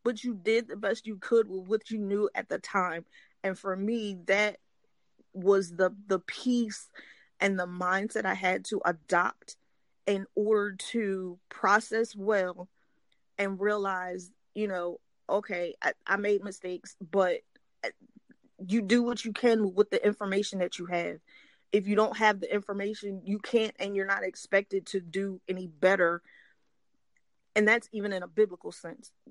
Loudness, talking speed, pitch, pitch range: -30 LUFS, 160 wpm, 200 Hz, 190-215 Hz